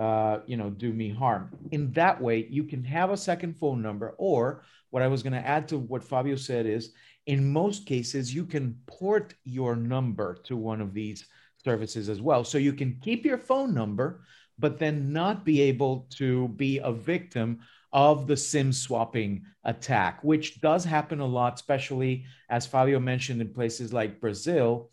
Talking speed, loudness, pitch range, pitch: 185 wpm, -28 LUFS, 115-150 Hz, 130 Hz